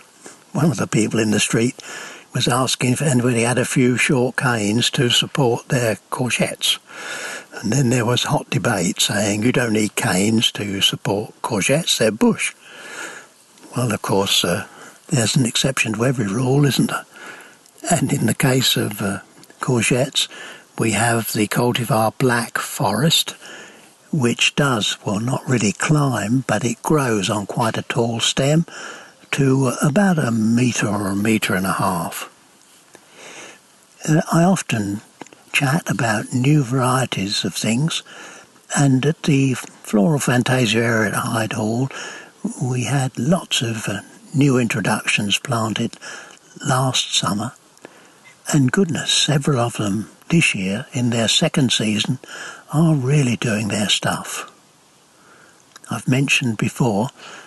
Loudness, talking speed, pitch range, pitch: -19 LUFS, 135 wpm, 110-145 Hz, 125 Hz